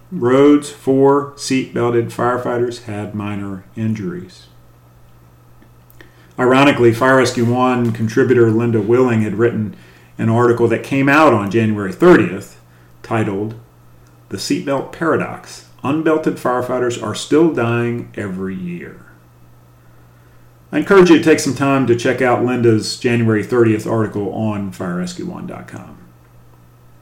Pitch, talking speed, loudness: 115 Hz, 110 wpm, -15 LUFS